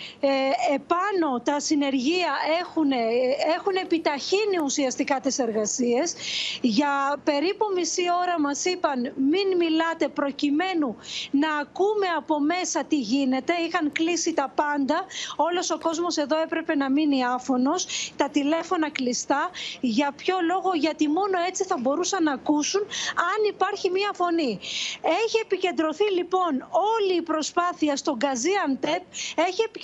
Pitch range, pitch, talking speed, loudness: 285-360 Hz, 320 Hz, 125 wpm, -24 LUFS